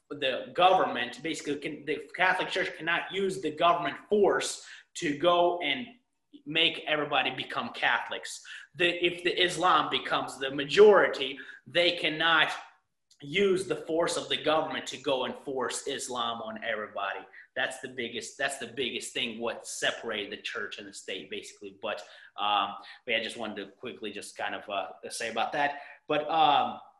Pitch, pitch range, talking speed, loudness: 175 Hz, 160-245 Hz, 160 wpm, -29 LUFS